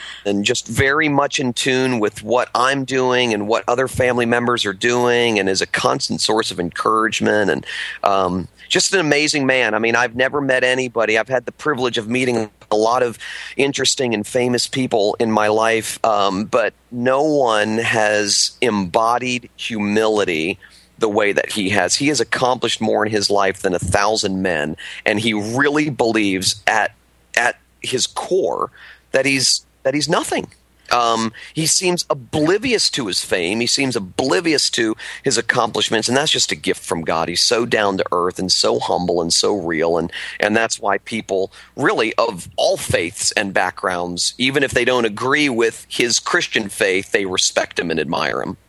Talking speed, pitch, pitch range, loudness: 185 wpm, 115 Hz, 105-130 Hz, -17 LUFS